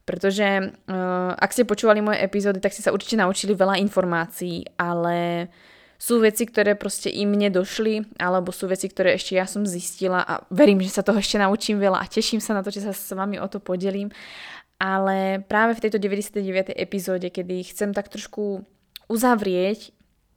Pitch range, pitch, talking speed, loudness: 185-205 Hz, 195 Hz, 175 wpm, -23 LUFS